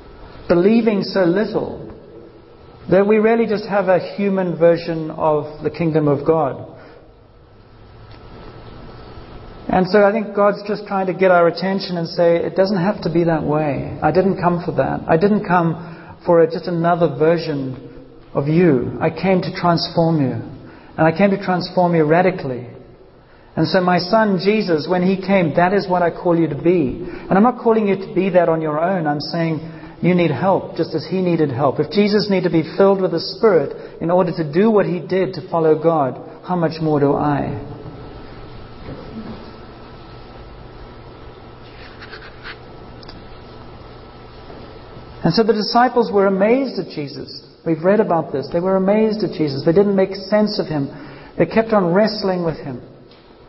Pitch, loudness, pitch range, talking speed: 175 Hz, -17 LUFS, 155-195 Hz, 170 wpm